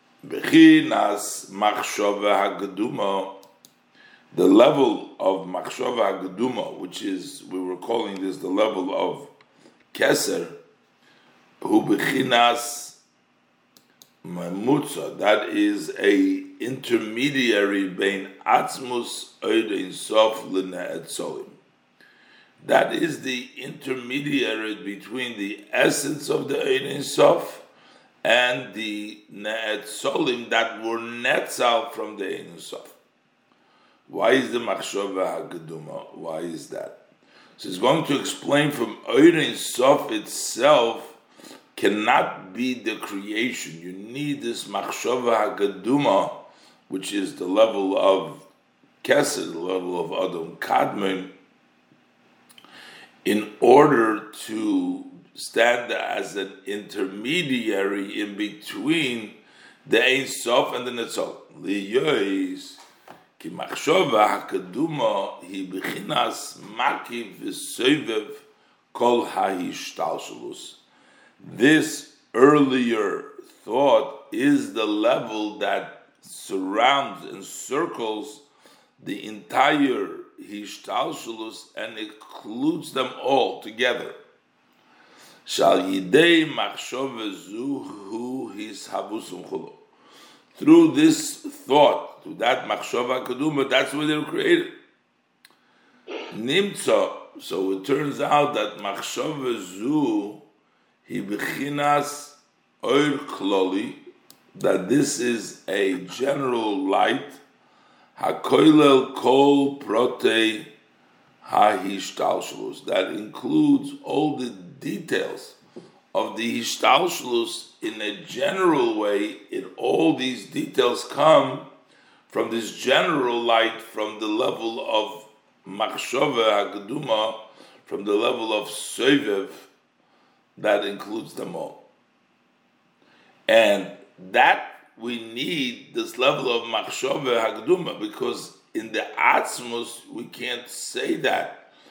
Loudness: -23 LUFS